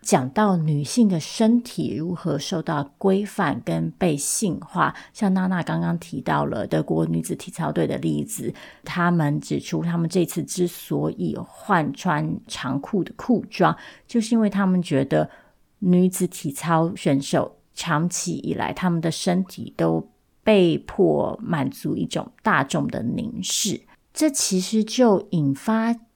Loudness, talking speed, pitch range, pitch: -23 LUFS, 215 characters per minute, 150-195 Hz, 175 Hz